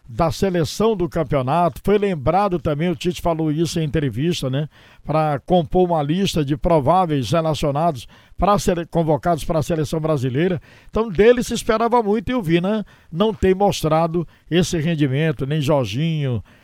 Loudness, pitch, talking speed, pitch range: -20 LUFS, 165 Hz, 160 wpm, 150-185 Hz